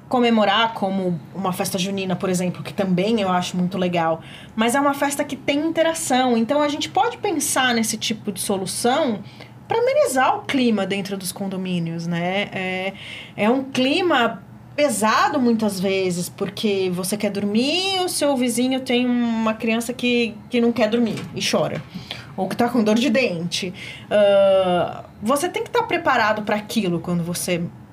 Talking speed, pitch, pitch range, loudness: 170 wpm, 215 Hz, 190-260 Hz, -21 LUFS